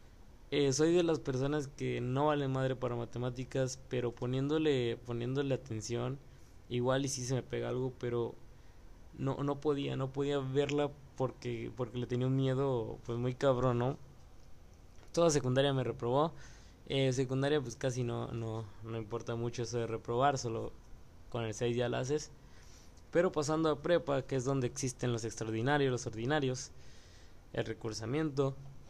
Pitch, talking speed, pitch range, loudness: 125 Hz, 160 wpm, 115-140 Hz, -35 LUFS